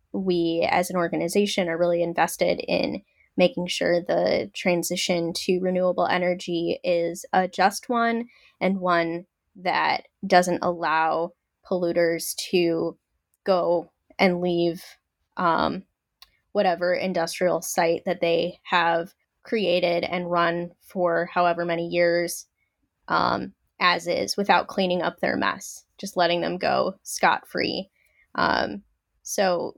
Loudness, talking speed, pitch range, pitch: -24 LUFS, 120 wpm, 170-180 Hz, 175 Hz